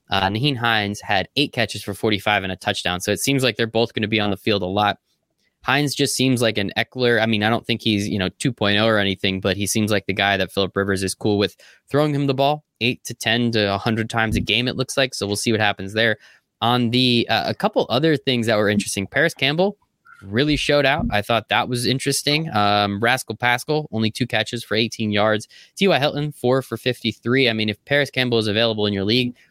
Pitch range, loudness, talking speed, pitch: 105-130 Hz, -20 LUFS, 245 wpm, 115 Hz